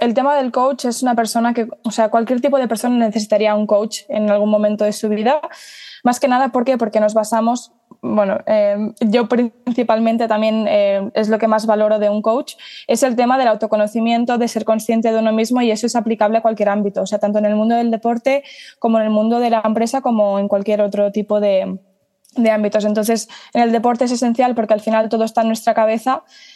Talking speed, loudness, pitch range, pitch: 225 wpm, -16 LUFS, 215-245 Hz, 225 Hz